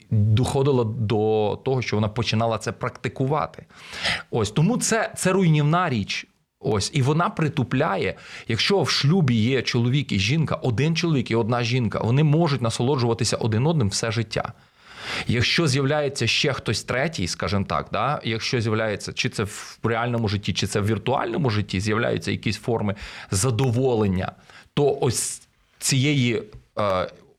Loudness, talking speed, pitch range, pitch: -23 LUFS, 140 wpm, 110-140 Hz, 120 Hz